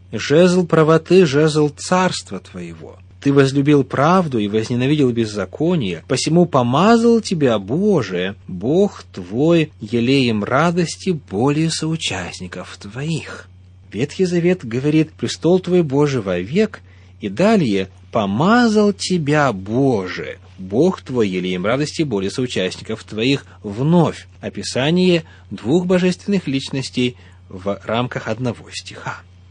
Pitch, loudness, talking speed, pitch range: 130 Hz, -17 LUFS, 100 wpm, 95-165 Hz